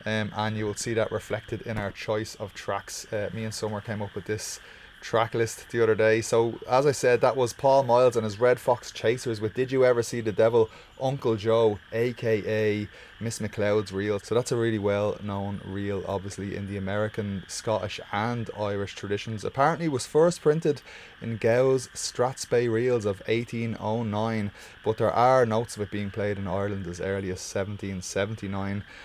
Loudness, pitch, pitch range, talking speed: -27 LUFS, 110 Hz, 100-115 Hz, 190 wpm